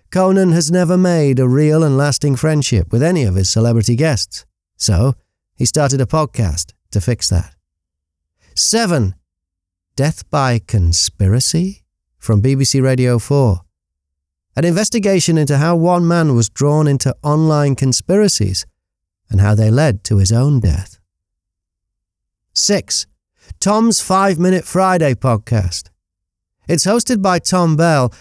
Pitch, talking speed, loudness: 125 Hz, 130 wpm, -14 LUFS